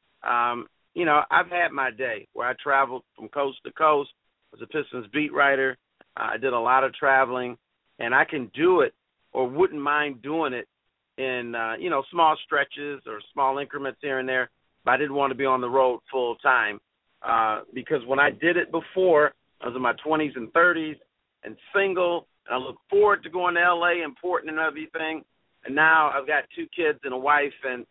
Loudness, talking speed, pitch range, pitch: -24 LUFS, 210 wpm, 130-160 Hz, 140 Hz